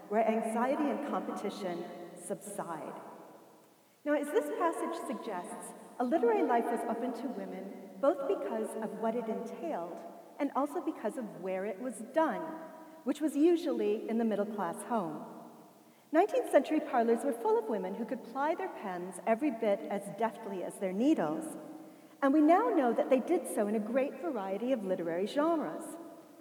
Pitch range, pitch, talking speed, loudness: 210-310 Hz, 240 Hz, 165 wpm, -33 LUFS